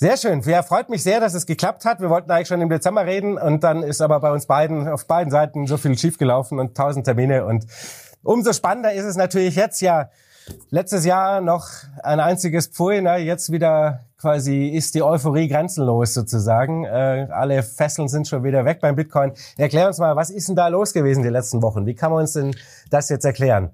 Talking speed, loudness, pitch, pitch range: 215 wpm, -19 LUFS, 155 Hz, 135-175 Hz